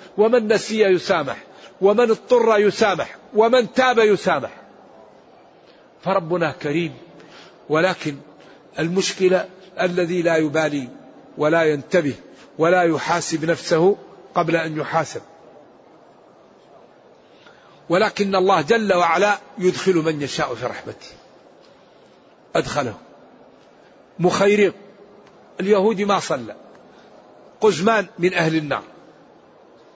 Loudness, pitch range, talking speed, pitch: -19 LUFS, 165-205 Hz, 85 wpm, 185 Hz